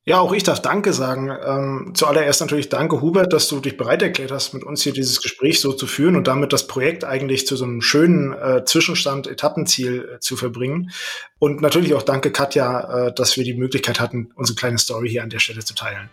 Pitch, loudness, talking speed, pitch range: 135 Hz, -19 LUFS, 210 wpm, 125-150 Hz